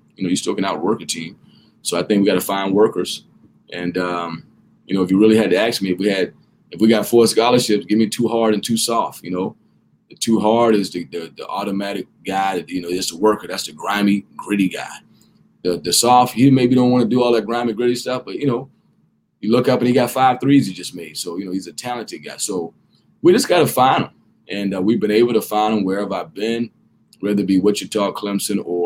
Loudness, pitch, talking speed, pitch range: -18 LUFS, 105 Hz, 255 wpm, 95-115 Hz